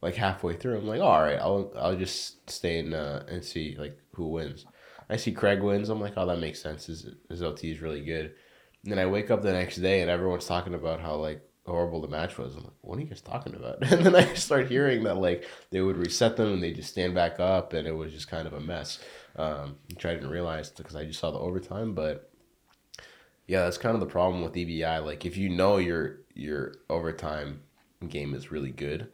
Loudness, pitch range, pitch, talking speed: -29 LUFS, 80-95 Hz, 85 Hz, 240 wpm